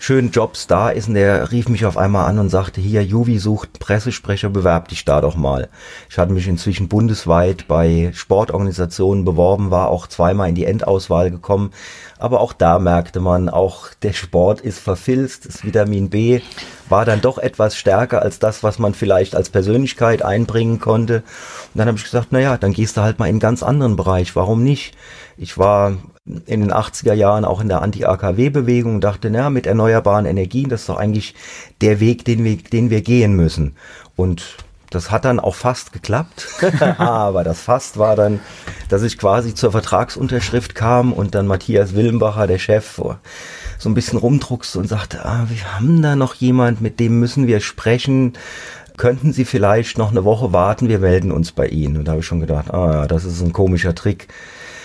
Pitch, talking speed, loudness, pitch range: 105 Hz, 195 wpm, -16 LUFS, 95-120 Hz